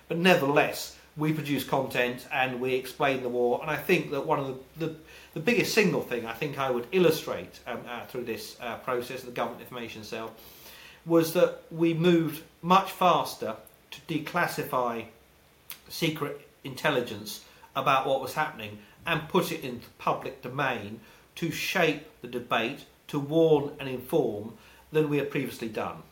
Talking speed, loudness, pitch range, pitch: 165 wpm, -28 LUFS, 125-160 Hz, 145 Hz